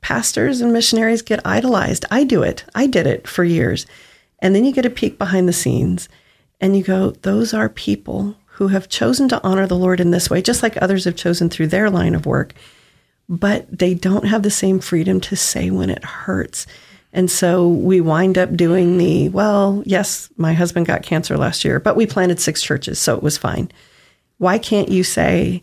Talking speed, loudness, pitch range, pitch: 205 wpm, -17 LUFS, 175-205 Hz, 185 Hz